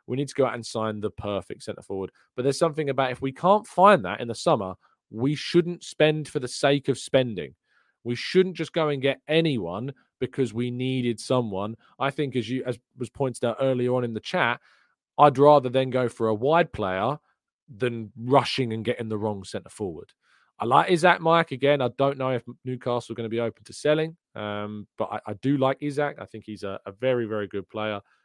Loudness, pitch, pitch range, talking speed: -25 LUFS, 125 Hz, 110-140 Hz, 220 wpm